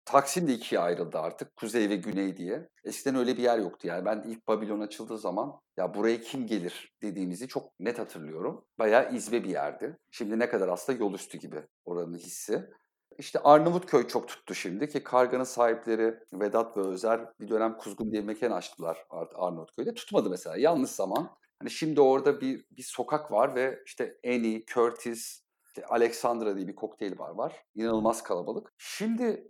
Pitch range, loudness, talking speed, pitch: 105-130 Hz, -30 LUFS, 175 wpm, 115 Hz